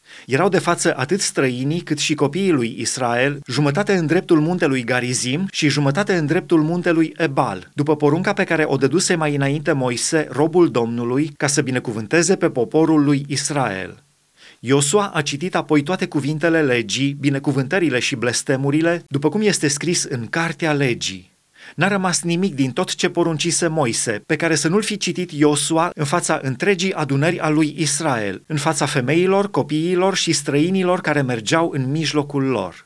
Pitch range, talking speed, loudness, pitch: 140-170 Hz, 165 wpm, -19 LUFS, 155 Hz